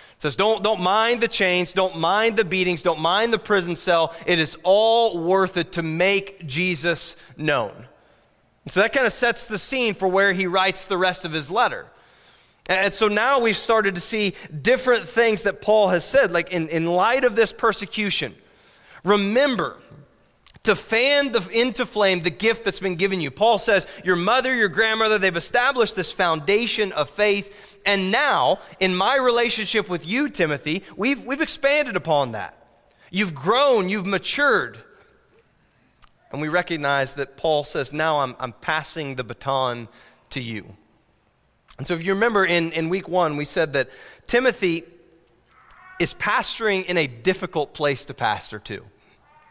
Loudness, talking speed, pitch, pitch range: -21 LUFS, 165 wpm, 190 Hz, 165-220 Hz